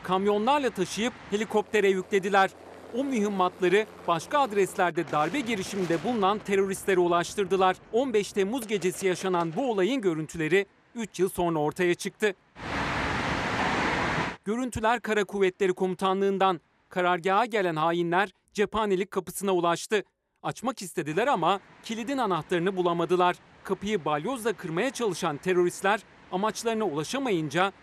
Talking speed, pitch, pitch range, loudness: 105 wpm, 190 Hz, 180-210 Hz, -27 LUFS